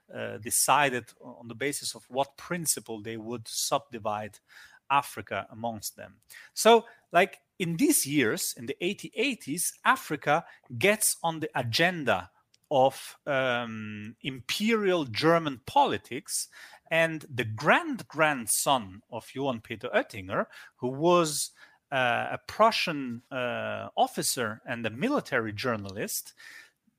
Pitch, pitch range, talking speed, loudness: 140 Hz, 115-175 Hz, 115 wpm, -28 LUFS